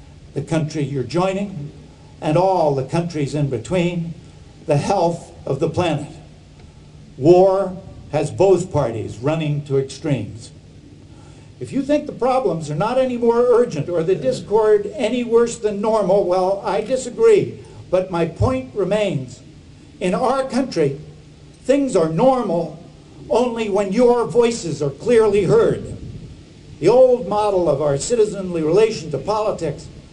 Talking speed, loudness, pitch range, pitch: 135 wpm, -18 LUFS, 150-220 Hz, 180 Hz